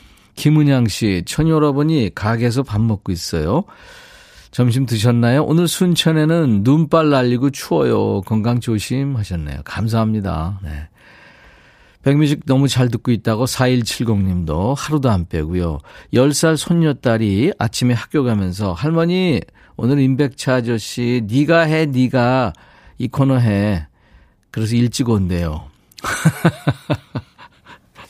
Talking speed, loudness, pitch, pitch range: 245 characters per minute, -17 LUFS, 120 Hz, 105-145 Hz